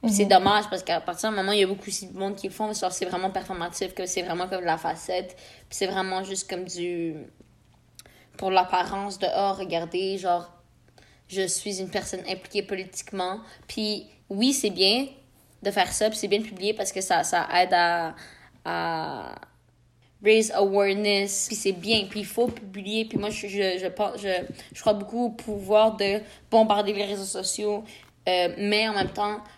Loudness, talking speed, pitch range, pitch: -26 LUFS, 190 wpm, 185-210 Hz, 195 Hz